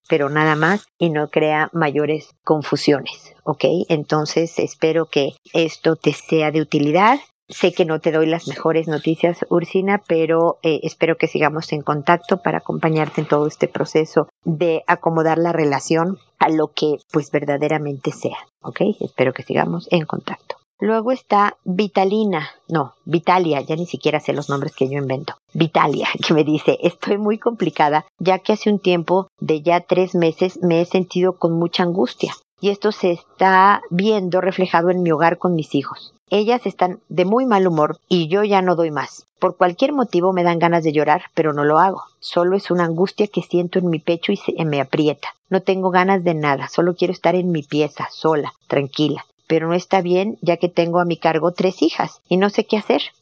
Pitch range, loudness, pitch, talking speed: 155-185 Hz, -19 LUFS, 170 Hz, 190 wpm